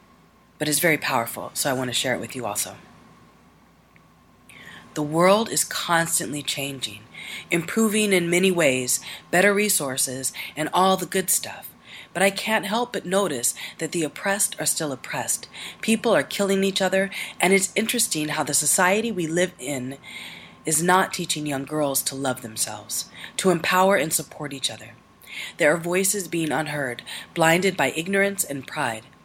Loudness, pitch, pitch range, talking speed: -22 LUFS, 165 Hz, 135-195 Hz, 160 wpm